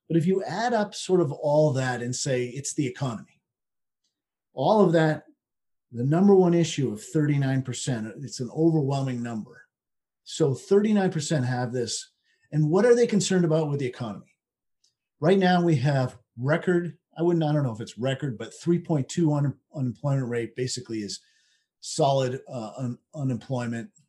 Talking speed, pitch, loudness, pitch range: 175 wpm, 145 Hz, -25 LUFS, 125-165 Hz